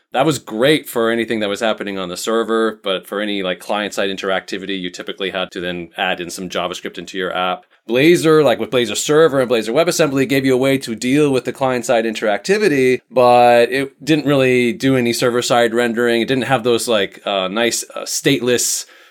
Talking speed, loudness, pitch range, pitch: 210 wpm, -16 LUFS, 100-130 Hz, 120 Hz